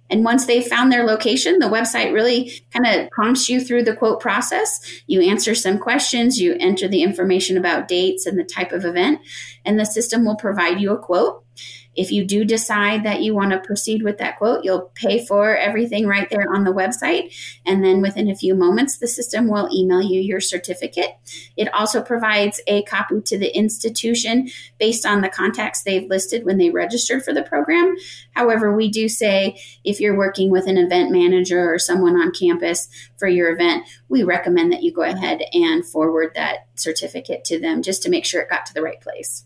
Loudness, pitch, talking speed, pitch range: -18 LUFS, 205 Hz, 205 wpm, 185-235 Hz